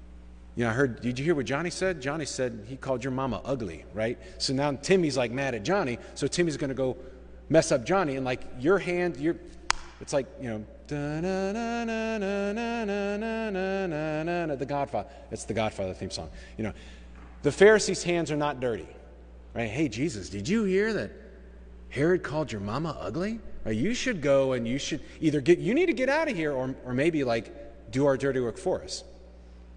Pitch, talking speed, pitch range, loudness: 145 Hz, 190 wpm, 115-185 Hz, -28 LUFS